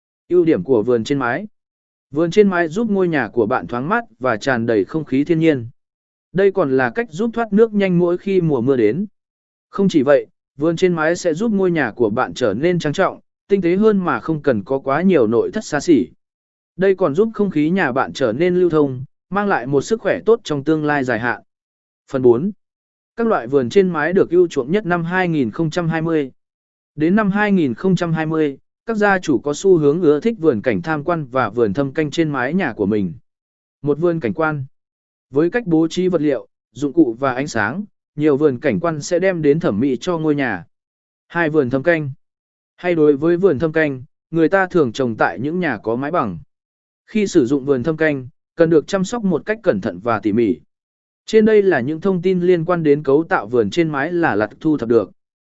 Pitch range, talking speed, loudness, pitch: 145-195 Hz, 225 wpm, -18 LUFS, 165 Hz